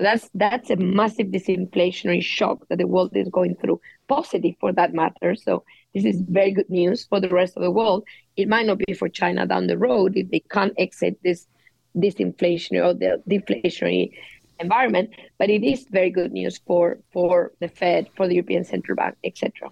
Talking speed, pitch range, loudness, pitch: 195 wpm, 180-210 Hz, -22 LUFS, 185 Hz